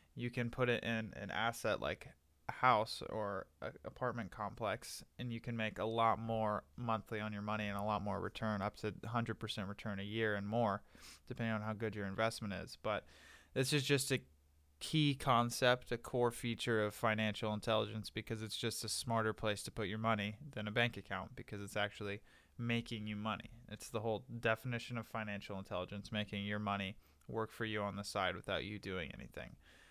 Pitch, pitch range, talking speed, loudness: 110 Hz, 105-115 Hz, 195 wpm, -40 LUFS